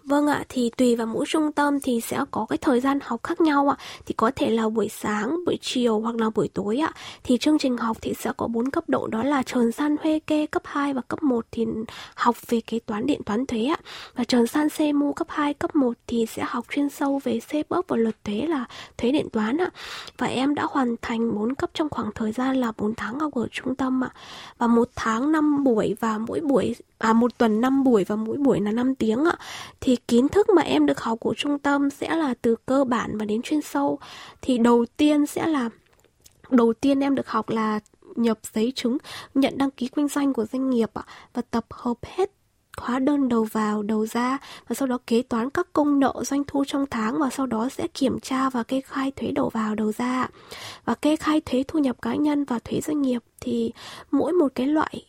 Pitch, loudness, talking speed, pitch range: 255 Hz, -24 LUFS, 240 wpm, 230-290 Hz